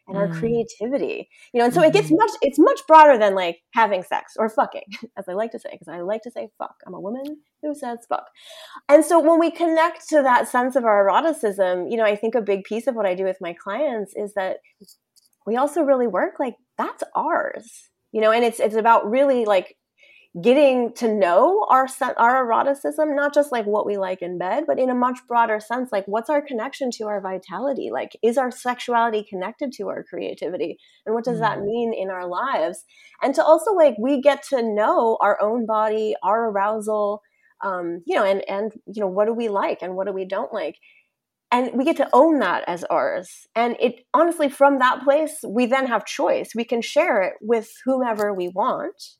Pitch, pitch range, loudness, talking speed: 235 Hz, 210-280 Hz, -21 LUFS, 215 wpm